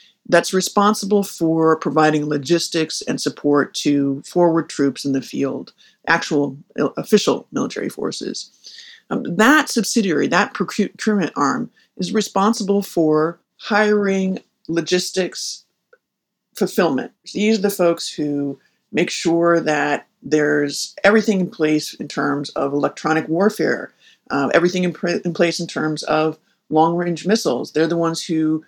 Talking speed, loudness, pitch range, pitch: 130 wpm, -19 LUFS, 155-205 Hz, 170 Hz